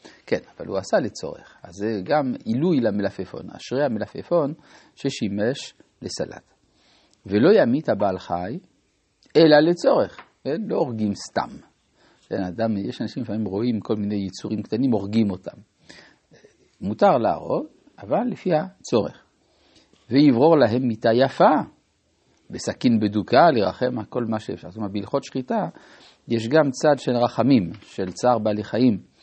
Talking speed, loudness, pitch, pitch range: 130 wpm, -22 LUFS, 110 Hz, 105-125 Hz